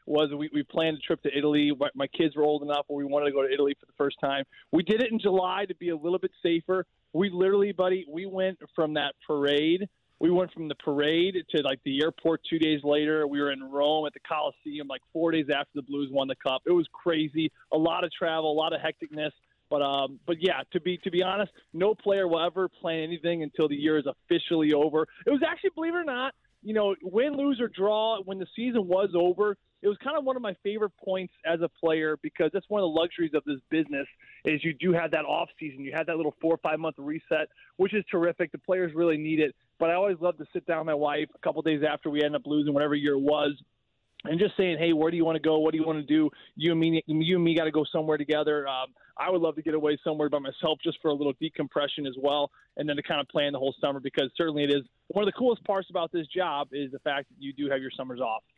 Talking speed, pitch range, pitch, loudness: 270 wpm, 145-180 Hz, 160 Hz, -28 LUFS